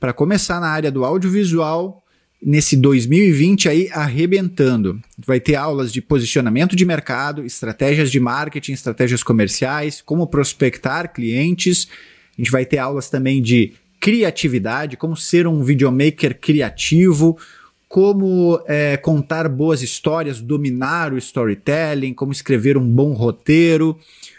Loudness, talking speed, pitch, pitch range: -17 LUFS, 125 wpm, 150 Hz, 130-165 Hz